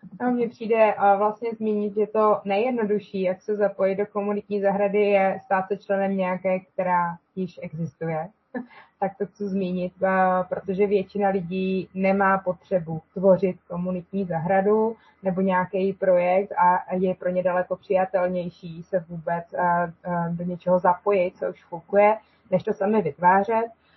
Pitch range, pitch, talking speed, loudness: 180-205 Hz, 190 Hz, 135 wpm, -24 LUFS